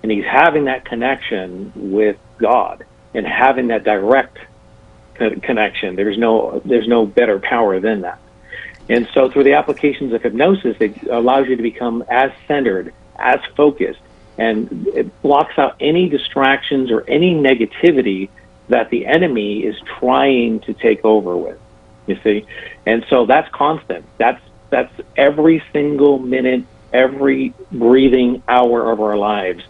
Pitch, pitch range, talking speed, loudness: 125 Hz, 110-135 Hz, 145 wpm, -15 LUFS